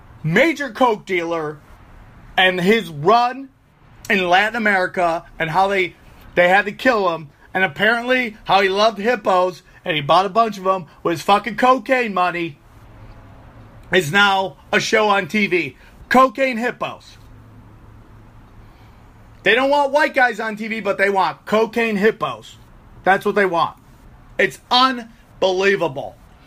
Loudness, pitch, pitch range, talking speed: -17 LUFS, 190 Hz, 150-225 Hz, 140 wpm